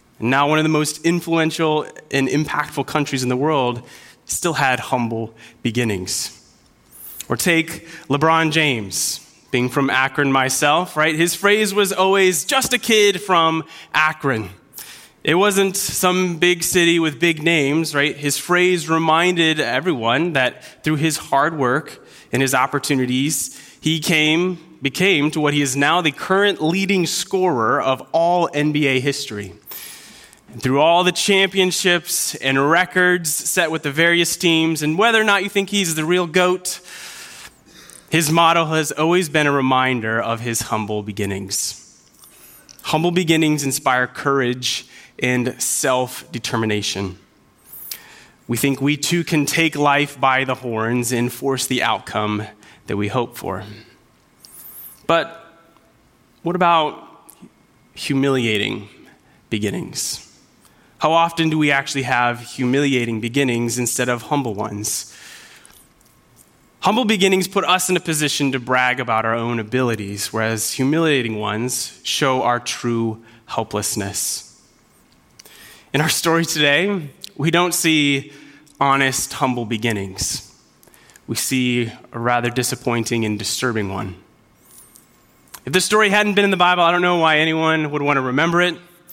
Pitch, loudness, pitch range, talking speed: 145 Hz, -18 LUFS, 125-170 Hz, 135 wpm